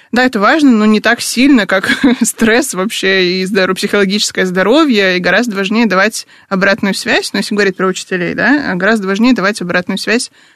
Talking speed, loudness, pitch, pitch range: 180 wpm, -11 LUFS, 205 Hz, 190-235 Hz